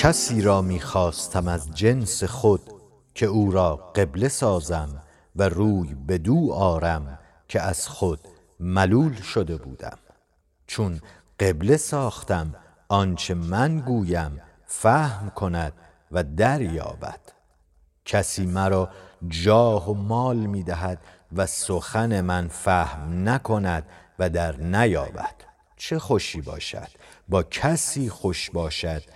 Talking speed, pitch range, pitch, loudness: 110 wpm, 85-105 Hz, 95 Hz, -24 LUFS